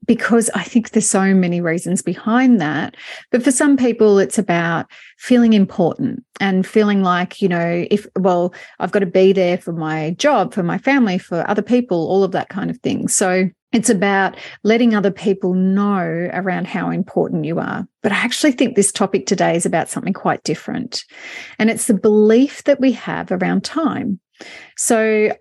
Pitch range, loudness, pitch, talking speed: 185-235 Hz, -17 LUFS, 200 Hz, 185 wpm